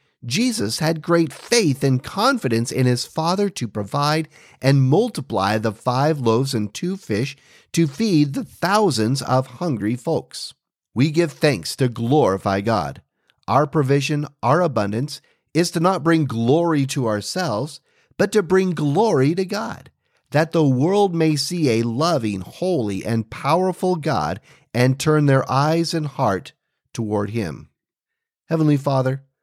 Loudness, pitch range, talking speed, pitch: -20 LUFS, 120-165 Hz, 145 wpm, 145 Hz